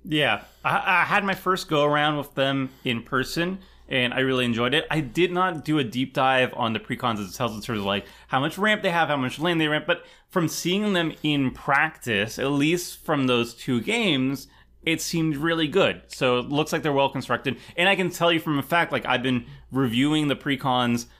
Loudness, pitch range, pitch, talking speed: -24 LUFS, 130-165 Hz, 145 Hz, 230 wpm